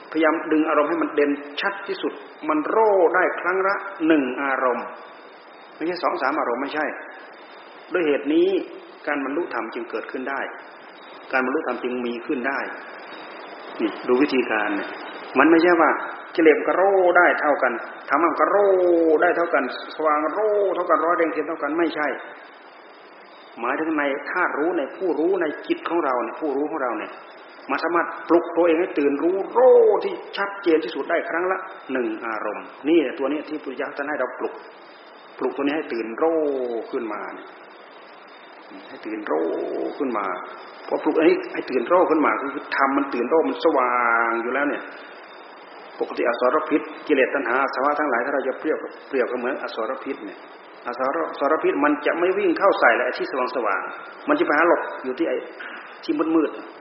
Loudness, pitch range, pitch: -22 LUFS, 150-210 Hz, 165 Hz